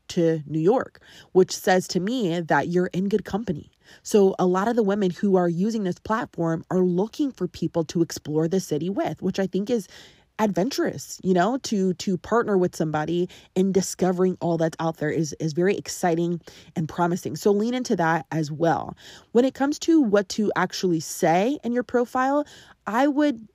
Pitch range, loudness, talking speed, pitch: 170-215 Hz, -24 LUFS, 190 wpm, 185 Hz